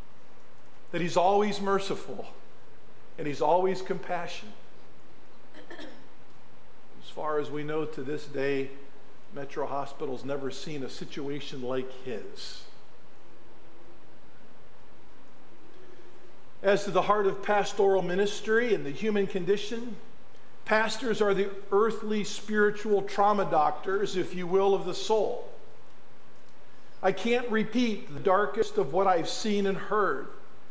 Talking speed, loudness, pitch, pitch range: 115 wpm, -29 LUFS, 195 Hz, 150-210 Hz